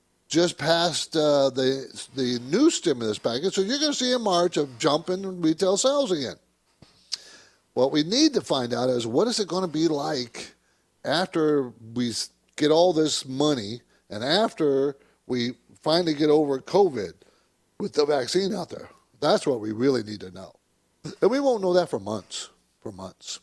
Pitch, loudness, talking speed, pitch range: 155 Hz, -24 LUFS, 180 wpm, 125-185 Hz